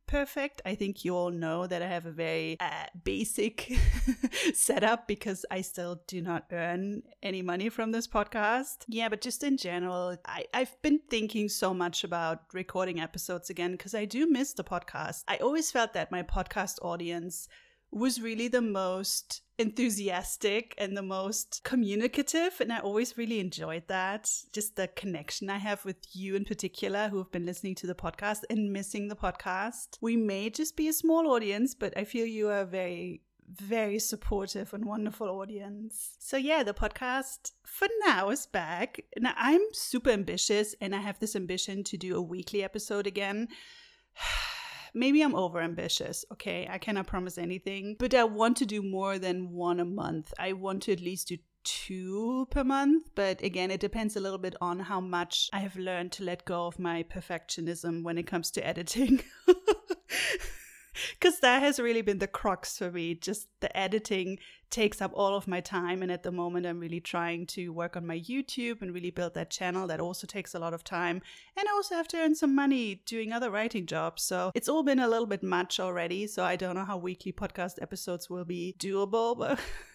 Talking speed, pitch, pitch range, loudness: 190 wpm, 200 Hz, 180-230 Hz, -32 LUFS